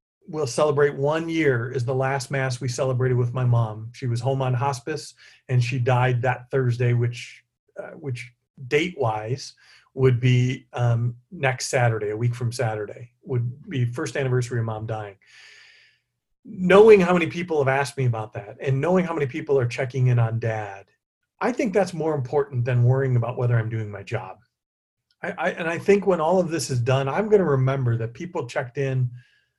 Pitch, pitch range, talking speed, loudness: 130 Hz, 120-150 Hz, 190 wpm, -23 LUFS